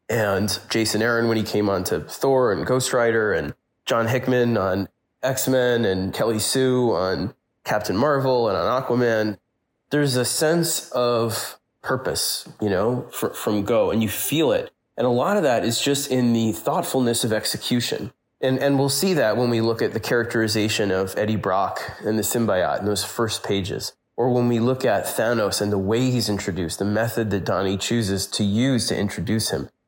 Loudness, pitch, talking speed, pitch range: -22 LUFS, 115 Hz, 190 wpm, 105-125 Hz